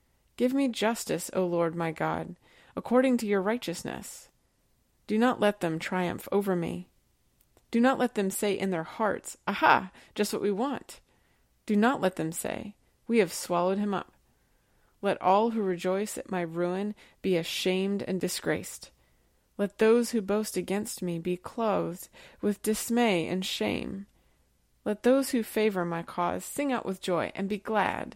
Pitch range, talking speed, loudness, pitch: 180-220 Hz, 165 wpm, -29 LUFS, 200 Hz